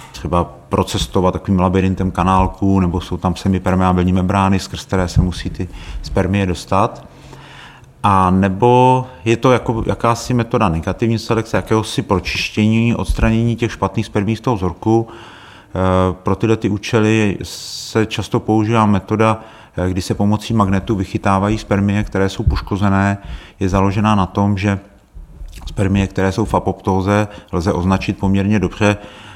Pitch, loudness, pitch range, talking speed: 100 Hz, -16 LUFS, 95-110 Hz, 135 wpm